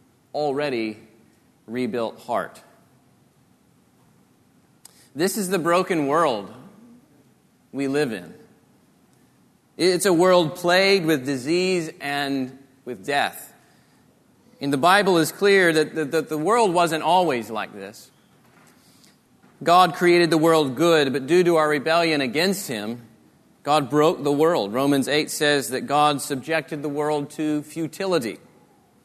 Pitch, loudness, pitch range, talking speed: 155 Hz, -21 LUFS, 140-175 Hz, 125 wpm